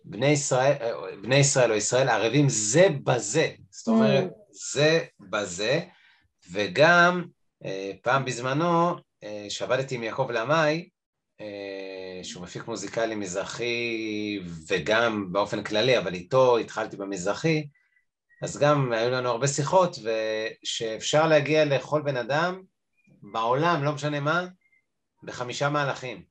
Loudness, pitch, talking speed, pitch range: -25 LUFS, 130 Hz, 110 wpm, 110-155 Hz